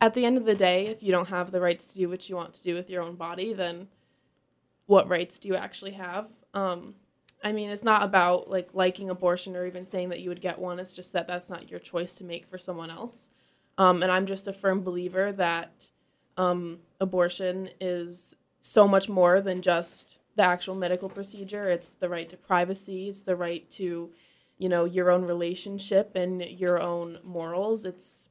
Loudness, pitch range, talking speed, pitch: -28 LUFS, 175-195 Hz, 210 wpm, 180 Hz